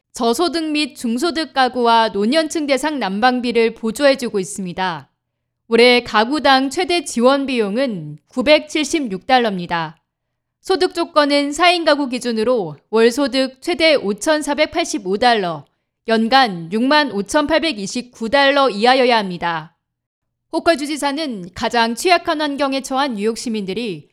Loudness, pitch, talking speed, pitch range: -17 LUFS, 255 Hz, 240 characters per minute, 225-300 Hz